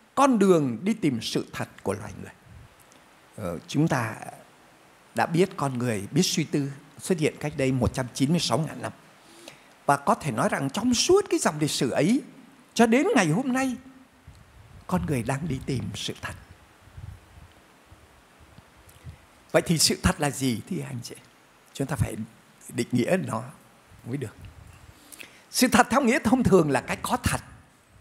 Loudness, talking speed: -25 LUFS, 165 wpm